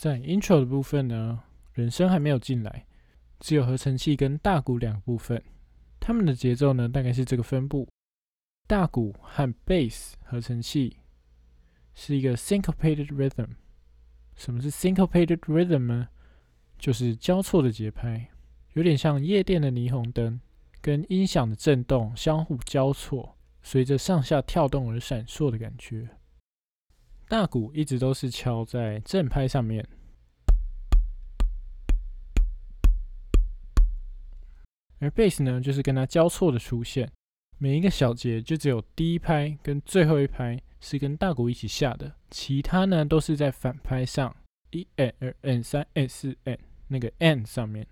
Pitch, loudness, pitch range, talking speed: 130 Hz, -26 LUFS, 110-150 Hz, 250 characters per minute